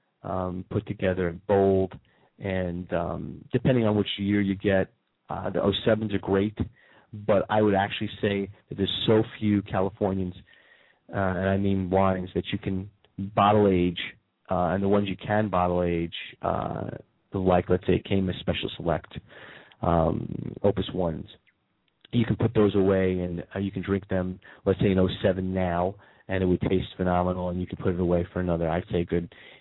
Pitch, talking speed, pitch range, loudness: 95 Hz, 180 wpm, 90-100 Hz, -26 LUFS